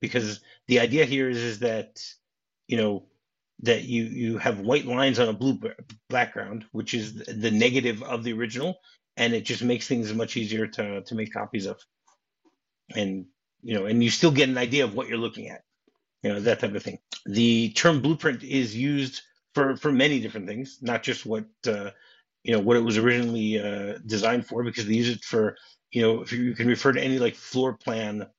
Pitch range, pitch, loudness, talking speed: 110-130 Hz, 120 Hz, -25 LUFS, 205 wpm